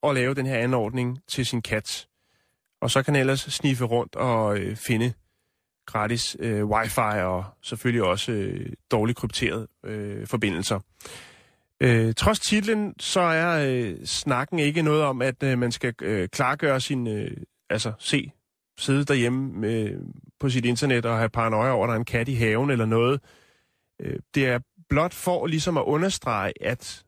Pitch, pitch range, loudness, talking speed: 125 Hz, 110-140 Hz, -25 LUFS, 170 wpm